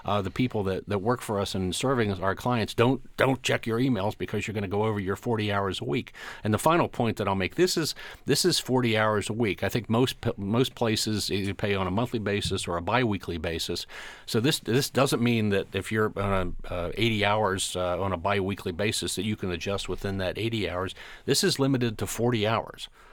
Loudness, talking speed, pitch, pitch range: -27 LUFS, 235 wpm, 105 Hz, 95-120 Hz